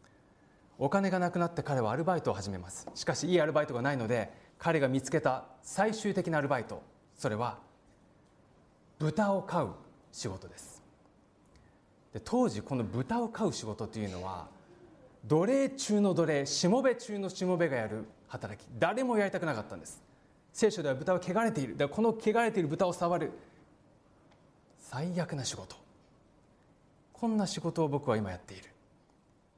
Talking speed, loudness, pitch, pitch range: 315 characters per minute, -32 LUFS, 160 Hz, 120-190 Hz